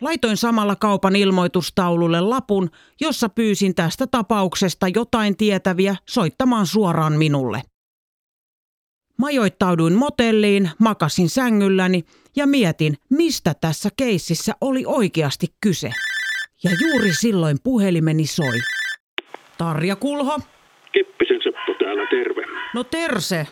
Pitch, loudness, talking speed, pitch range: 200 Hz, -19 LUFS, 95 wpm, 175-250 Hz